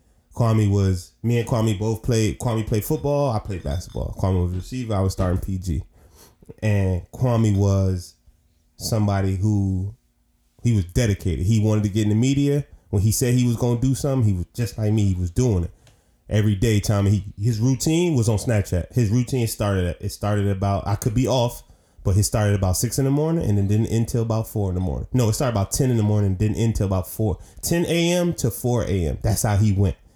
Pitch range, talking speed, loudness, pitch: 95-120 Hz, 225 wpm, -22 LUFS, 105 Hz